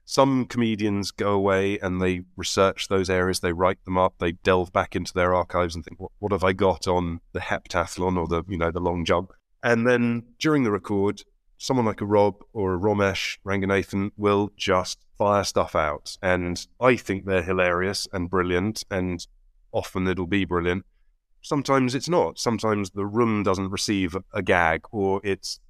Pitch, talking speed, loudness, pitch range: 95 Hz, 180 wpm, -24 LUFS, 90-105 Hz